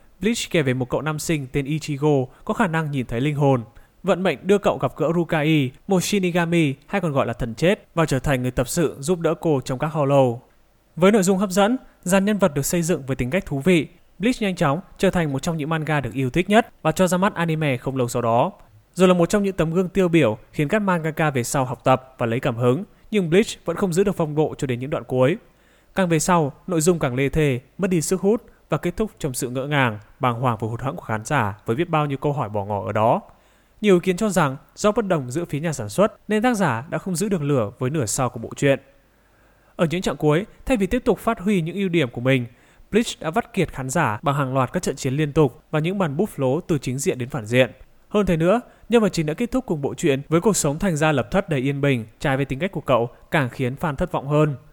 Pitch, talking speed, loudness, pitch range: 155 Hz, 275 wpm, -22 LUFS, 135-185 Hz